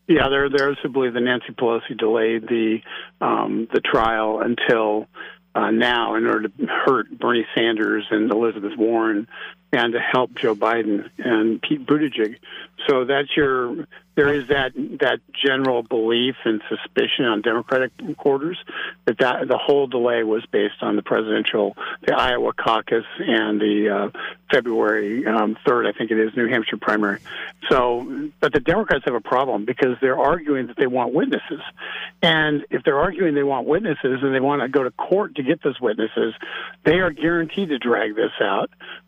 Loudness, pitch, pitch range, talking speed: -21 LUFS, 120 Hz, 110-145 Hz, 170 wpm